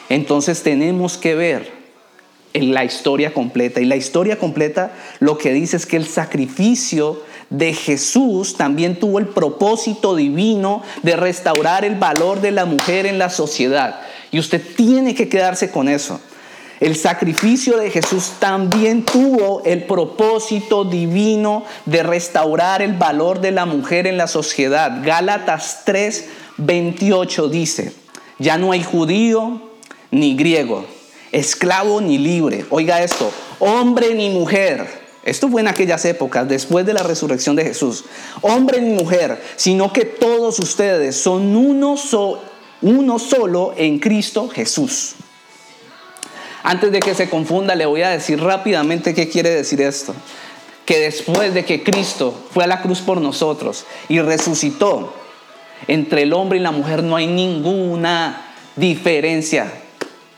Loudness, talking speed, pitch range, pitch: -16 LUFS, 140 wpm, 160-210 Hz, 180 Hz